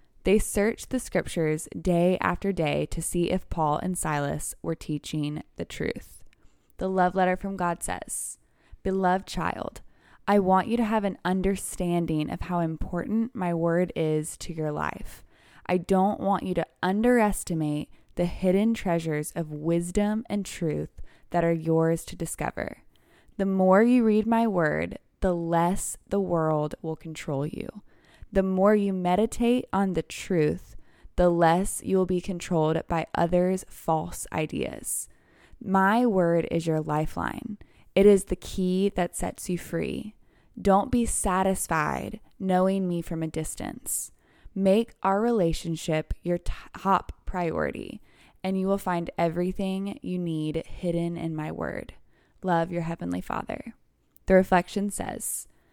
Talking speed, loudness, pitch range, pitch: 145 wpm, -27 LUFS, 165-195 Hz, 180 Hz